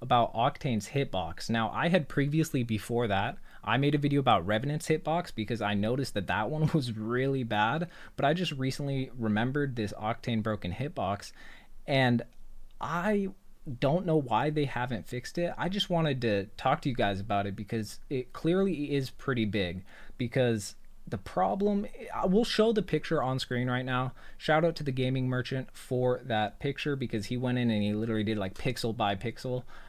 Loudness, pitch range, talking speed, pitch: -30 LUFS, 110-150 Hz, 185 wpm, 125 Hz